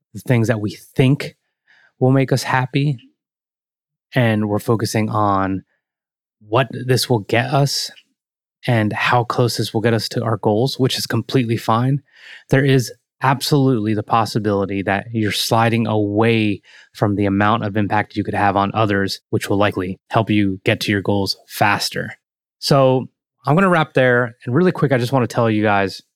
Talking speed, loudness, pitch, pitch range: 175 wpm, -18 LUFS, 115 Hz, 105-130 Hz